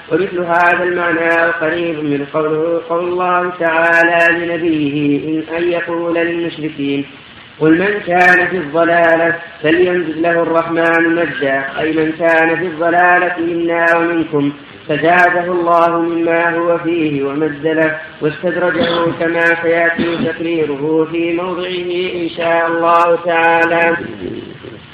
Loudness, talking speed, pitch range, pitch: -14 LUFS, 110 wpm, 160-170 Hz, 170 Hz